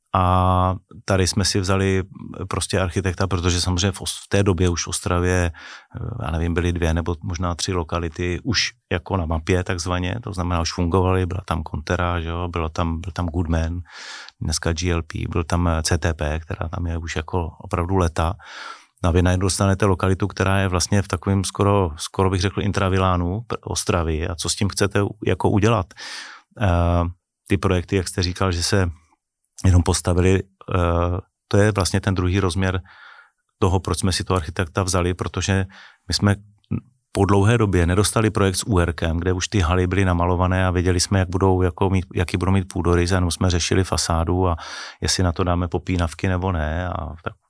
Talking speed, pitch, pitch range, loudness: 175 wpm, 90 Hz, 85-100 Hz, -21 LUFS